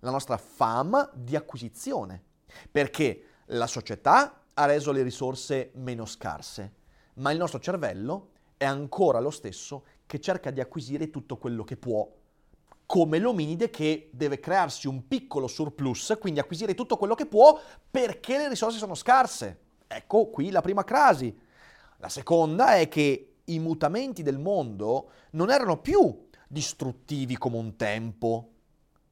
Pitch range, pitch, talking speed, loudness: 130-180 Hz, 145 Hz, 140 wpm, -27 LUFS